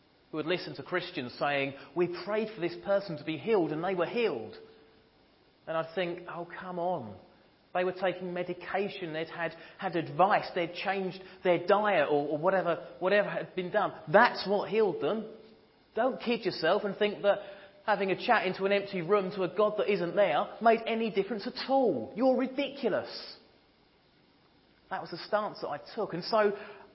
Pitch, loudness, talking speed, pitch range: 190 Hz, -31 LUFS, 185 wpm, 175-210 Hz